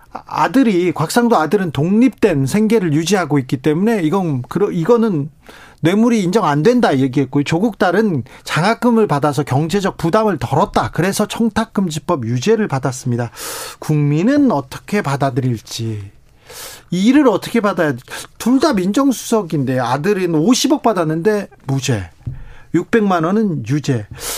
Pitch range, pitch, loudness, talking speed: 145-220 Hz, 175 Hz, -16 LUFS, 300 characters per minute